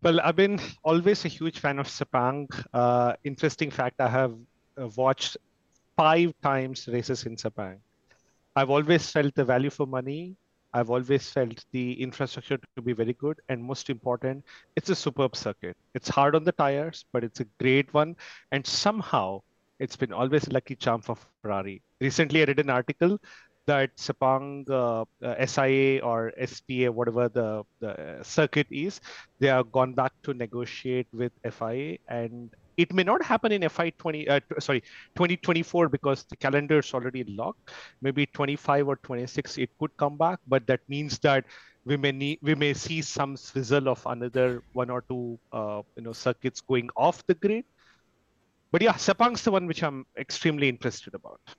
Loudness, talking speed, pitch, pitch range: -27 LUFS, 175 wpm, 135 Hz, 125-150 Hz